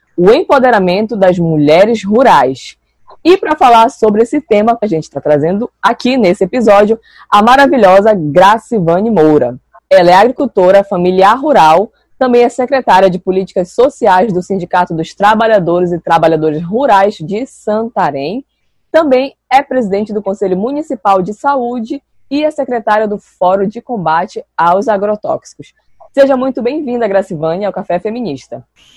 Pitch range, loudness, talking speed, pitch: 185-250 Hz, -10 LUFS, 140 wpm, 210 Hz